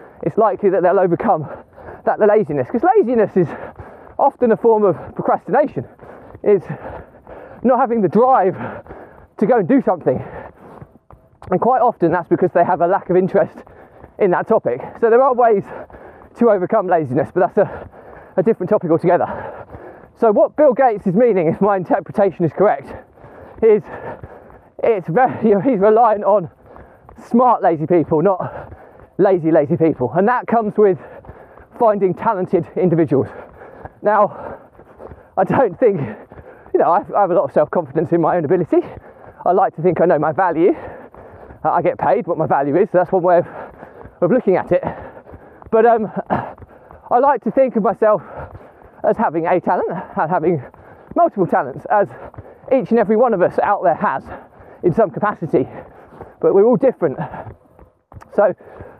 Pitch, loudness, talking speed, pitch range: 205 Hz, -16 LUFS, 170 wpm, 180-240 Hz